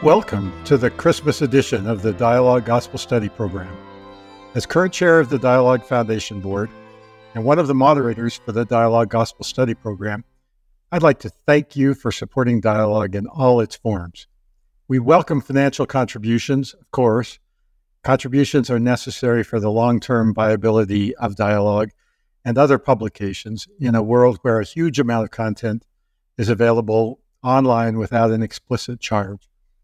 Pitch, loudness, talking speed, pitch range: 115 Hz, -18 LUFS, 155 wpm, 105-130 Hz